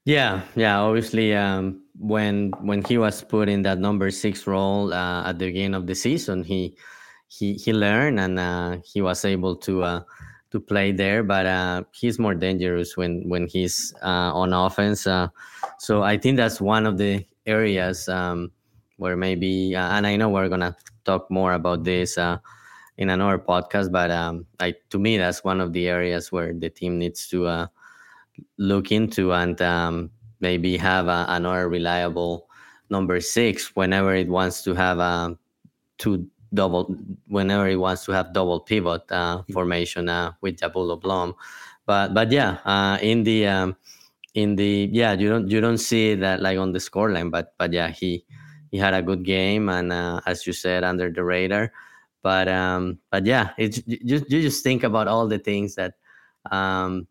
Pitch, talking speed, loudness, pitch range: 95 Hz, 180 wpm, -23 LUFS, 90-105 Hz